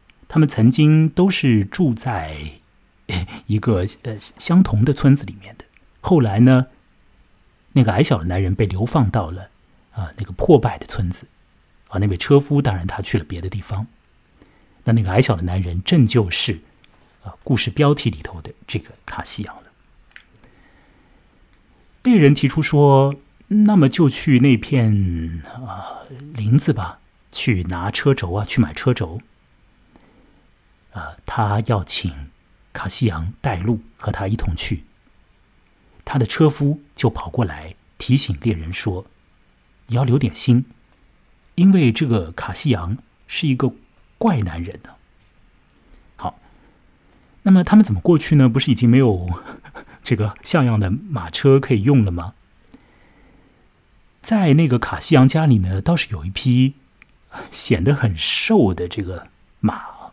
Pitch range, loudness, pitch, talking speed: 95-135 Hz, -18 LUFS, 115 Hz, 205 characters per minute